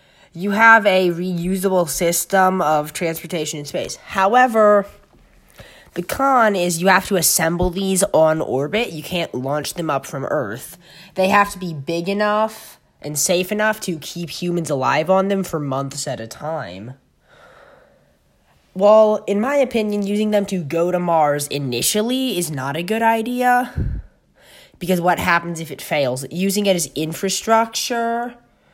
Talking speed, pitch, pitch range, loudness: 150 wpm, 185 Hz, 160-210 Hz, -18 LUFS